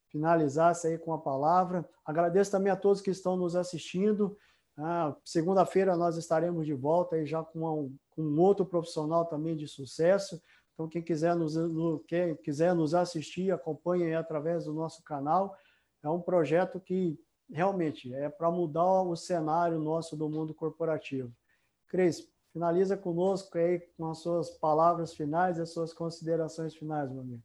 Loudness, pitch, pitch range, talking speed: -31 LUFS, 165 Hz, 155-175 Hz, 160 wpm